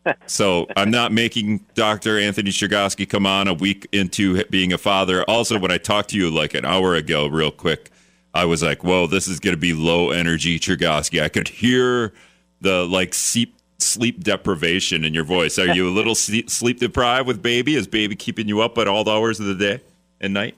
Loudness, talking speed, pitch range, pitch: -19 LUFS, 205 wpm, 90-110 Hz, 100 Hz